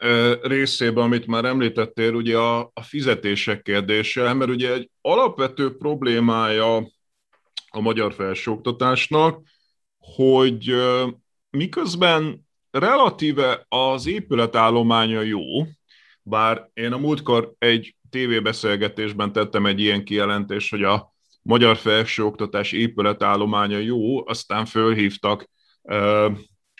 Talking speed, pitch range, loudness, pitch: 90 wpm, 105-125 Hz, -20 LUFS, 115 Hz